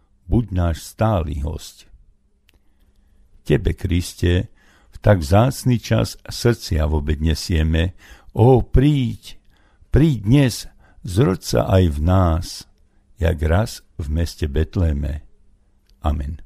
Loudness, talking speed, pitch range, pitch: -20 LUFS, 105 wpm, 75-105 Hz, 90 Hz